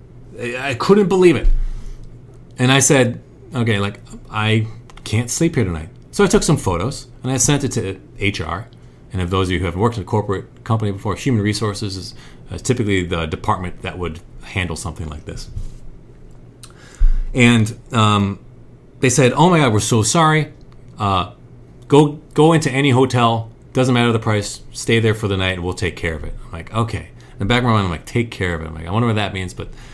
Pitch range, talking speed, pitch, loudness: 100-125 Hz, 210 wpm, 115 Hz, -18 LUFS